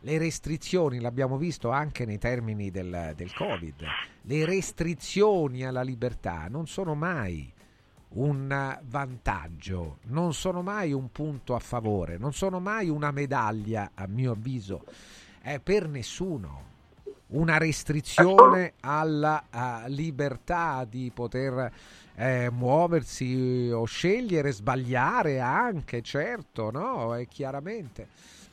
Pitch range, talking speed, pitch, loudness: 115-155 Hz, 110 wpm, 130 Hz, -28 LUFS